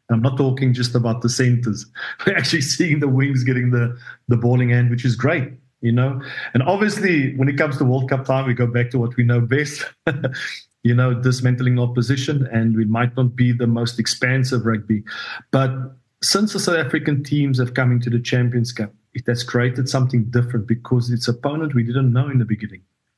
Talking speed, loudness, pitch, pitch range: 200 wpm, -19 LUFS, 125 Hz, 120-135 Hz